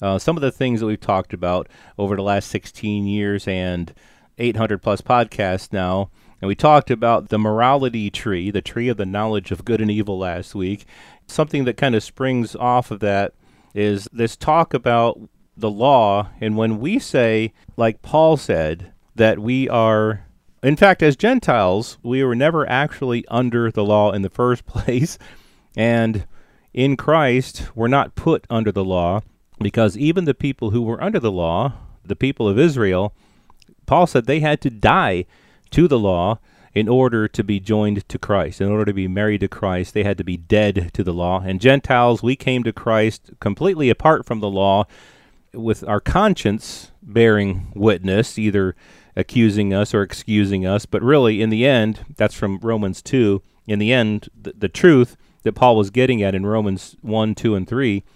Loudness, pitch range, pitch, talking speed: -19 LUFS, 100-125 Hz, 110 Hz, 185 wpm